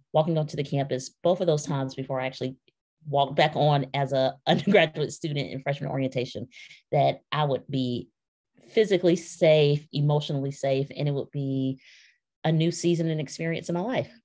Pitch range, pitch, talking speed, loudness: 135-160 Hz, 145 Hz, 175 wpm, -26 LUFS